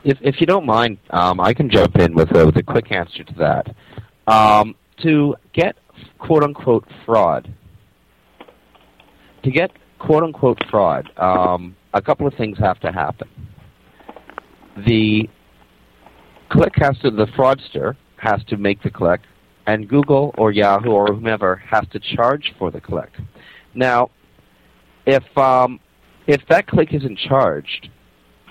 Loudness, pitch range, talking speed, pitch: -17 LUFS, 95-140 Hz, 145 wpm, 110 Hz